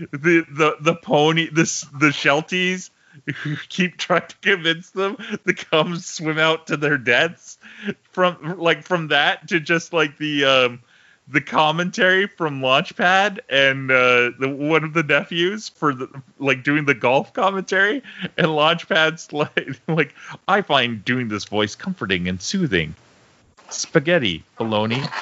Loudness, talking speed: -19 LUFS, 145 wpm